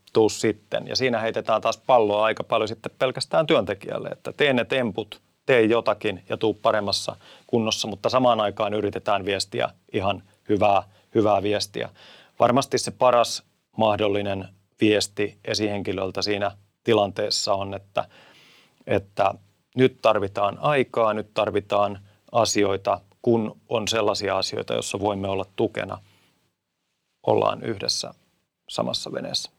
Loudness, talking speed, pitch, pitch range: -24 LUFS, 120 wpm, 105 Hz, 100-110 Hz